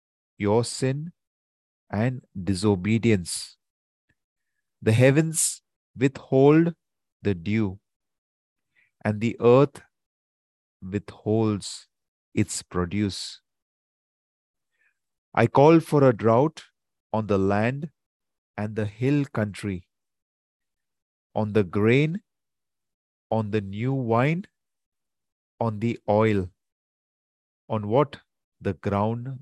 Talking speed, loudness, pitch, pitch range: 85 wpm, -24 LUFS, 105 Hz, 95-120 Hz